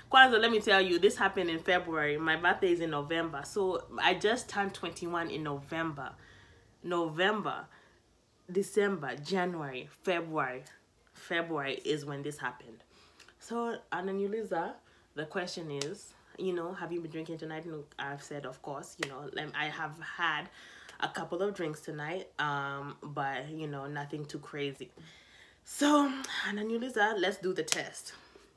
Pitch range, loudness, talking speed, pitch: 145-195 Hz, -33 LUFS, 145 wpm, 165 Hz